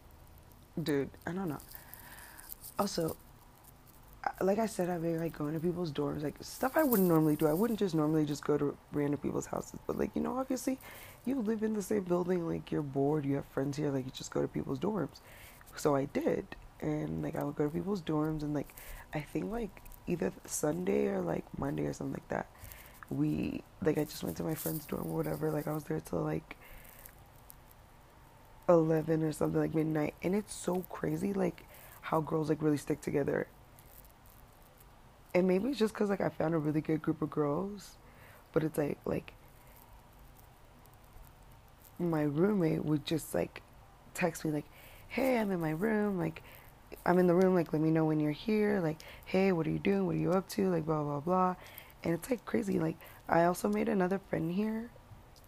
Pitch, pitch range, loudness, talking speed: 160 Hz, 145-185 Hz, -34 LUFS, 200 wpm